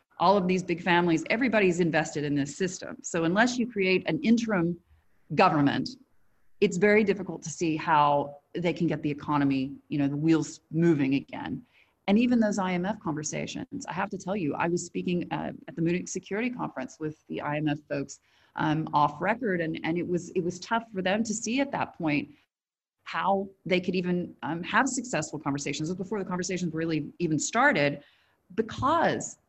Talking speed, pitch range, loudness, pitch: 185 wpm, 150-195 Hz, -28 LUFS, 175 Hz